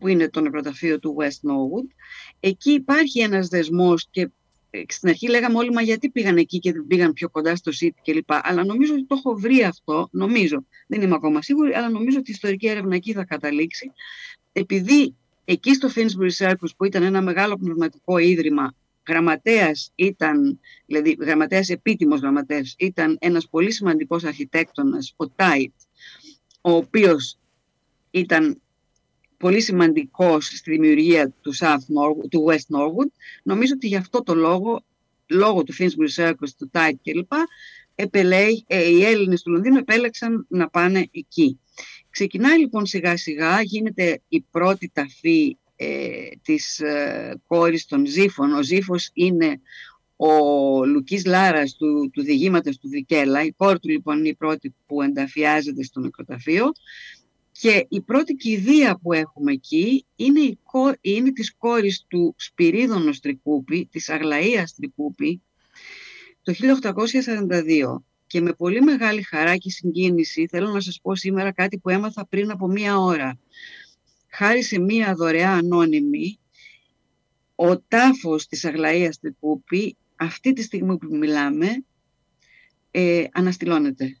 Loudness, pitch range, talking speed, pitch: -20 LUFS, 160-235 Hz, 145 wpm, 185 Hz